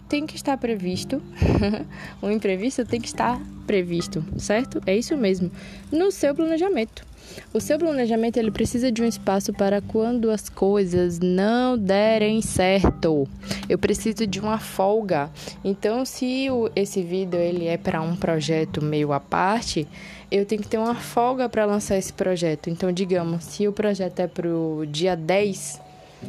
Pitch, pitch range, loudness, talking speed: 200 Hz, 180-225 Hz, -23 LUFS, 160 wpm